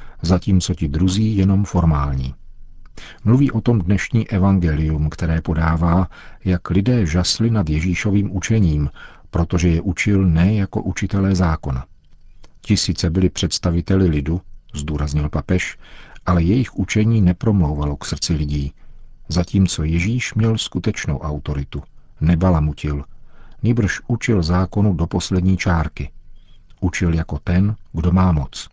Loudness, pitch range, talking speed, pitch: -19 LUFS, 80-100 Hz, 120 wpm, 90 Hz